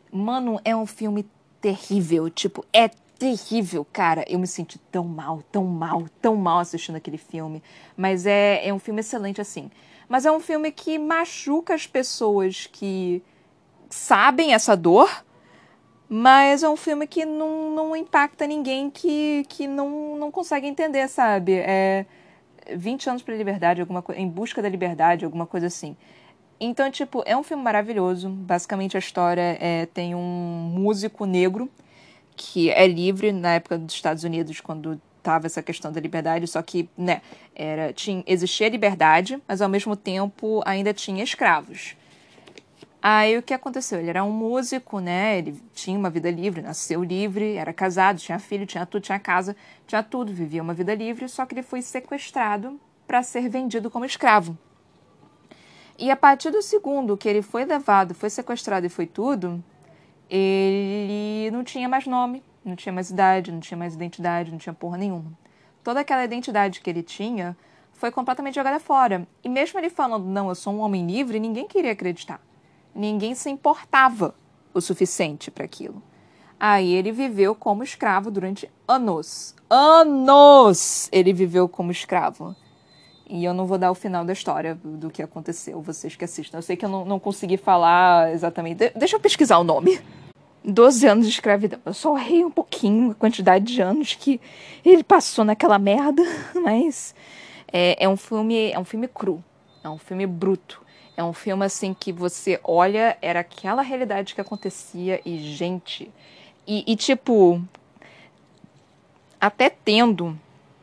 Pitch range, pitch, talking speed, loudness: 175-250 Hz, 200 Hz, 165 wpm, -21 LUFS